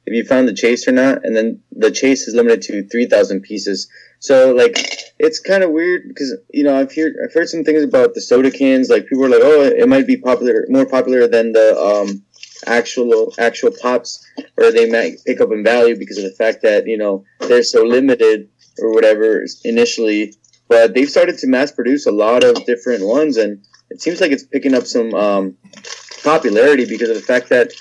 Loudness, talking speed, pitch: -14 LUFS, 215 wpm, 155 Hz